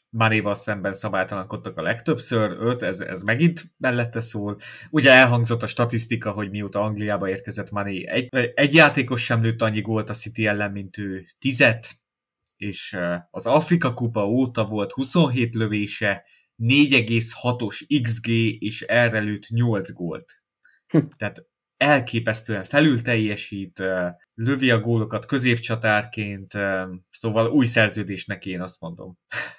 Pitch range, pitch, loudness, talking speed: 100-120 Hz, 110 Hz, -21 LUFS, 125 wpm